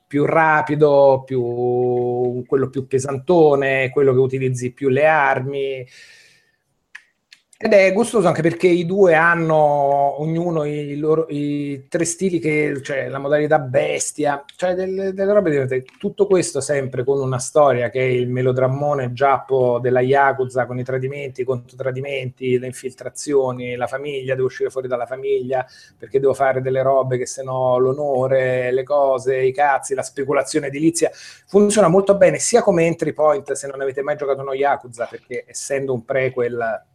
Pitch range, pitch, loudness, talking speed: 130-155 Hz, 140 Hz, -18 LUFS, 160 wpm